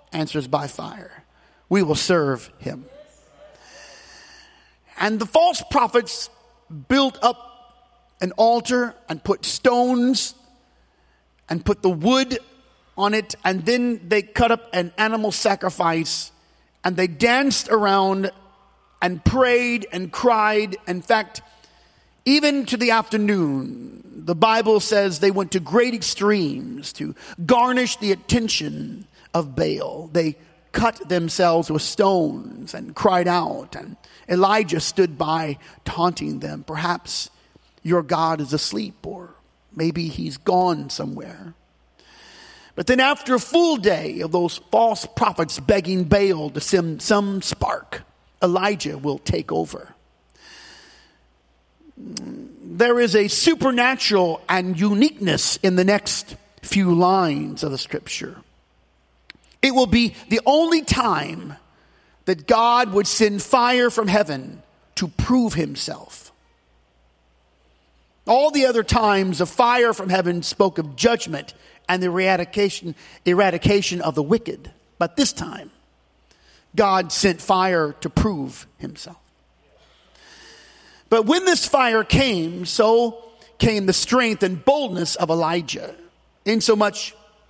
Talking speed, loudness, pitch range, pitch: 120 wpm, -20 LUFS, 175-240 Hz, 200 Hz